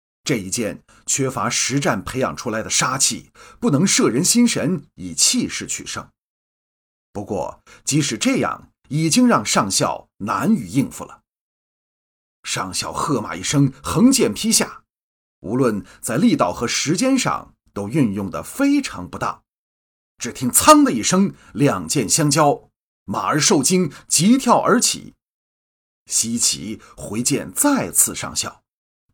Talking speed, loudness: 195 characters per minute, -18 LUFS